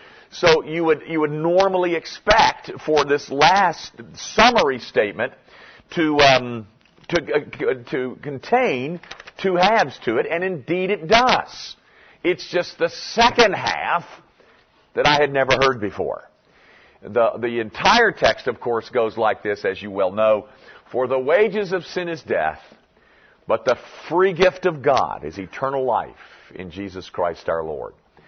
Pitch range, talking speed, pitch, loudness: 130-185 Hz, 150 wpm, 160 Hz, -20 LUFS